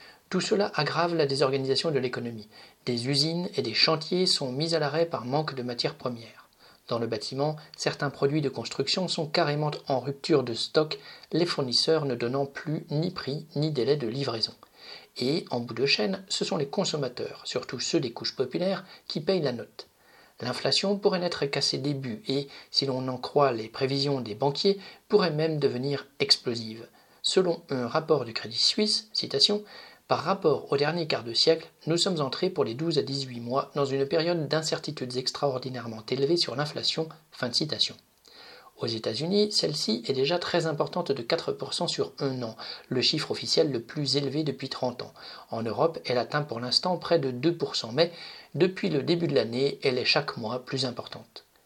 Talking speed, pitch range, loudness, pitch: 185 wpm, 130-165 Hz, -27 LUFS, 145 Hz